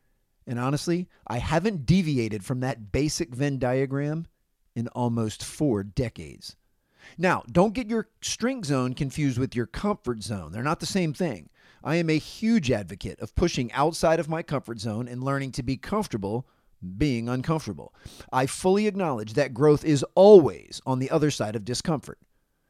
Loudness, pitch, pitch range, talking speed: -25 LUFS, 140 Hz, 120-165 Hz, 165 wpm